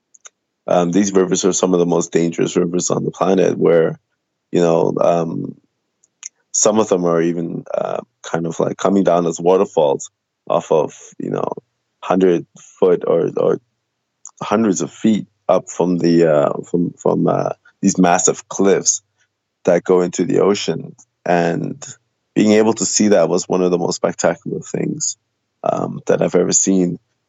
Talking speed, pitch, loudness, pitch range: 165 wpm, 90 Hz, -17 LUFS, 85-110 Hz